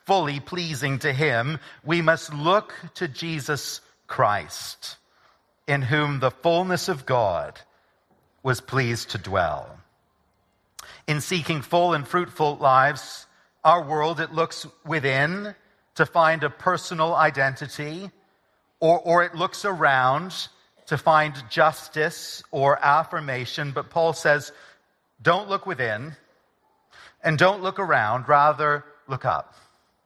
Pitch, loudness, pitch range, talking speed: 155 Hz, -23 LUFS, 140-170 Hz, 120 wpm